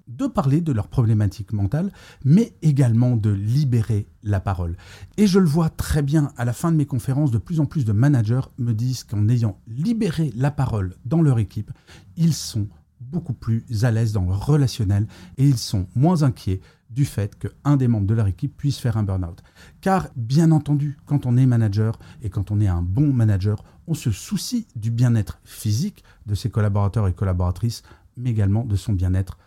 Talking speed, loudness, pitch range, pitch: 195 wpm, -22 LUFS, 105-145 Hz, 120 Hz